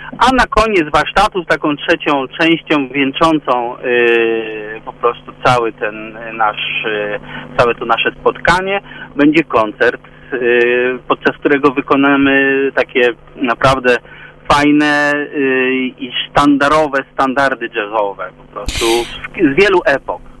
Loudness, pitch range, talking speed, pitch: -13 LUFS, 120-155 Hz, 115 wpm, 140 Hz